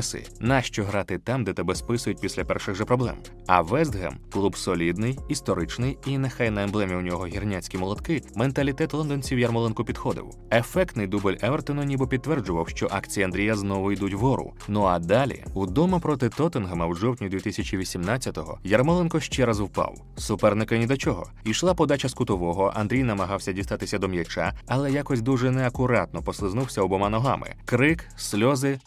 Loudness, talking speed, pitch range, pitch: -25 LUFS, 155 wpm, 95-130 Hz, 110 Hz